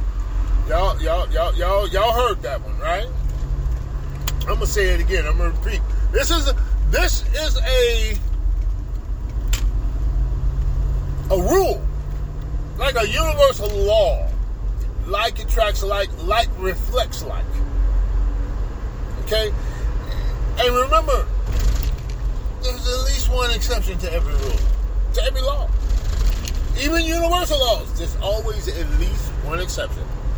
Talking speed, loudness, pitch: 115 wpm, -22 LUFS, 95 Hz